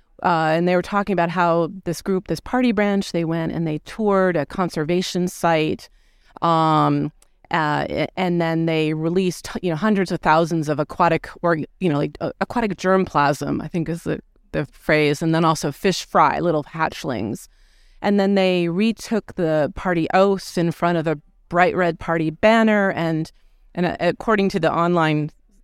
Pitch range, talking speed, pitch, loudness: 160-190 Hz, 175 wpm, 170 Hz, -20 LUFS